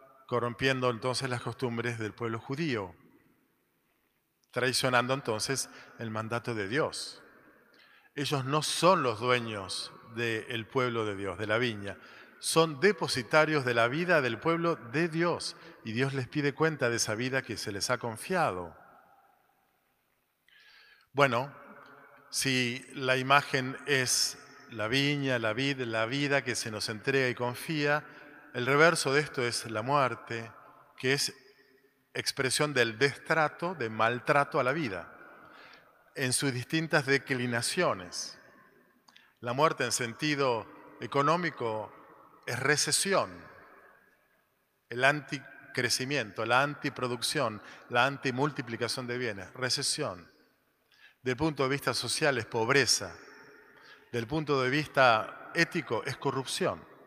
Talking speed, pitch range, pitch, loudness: 120 wpm, 120-145 Hz, 135 Hz, -30 LUFS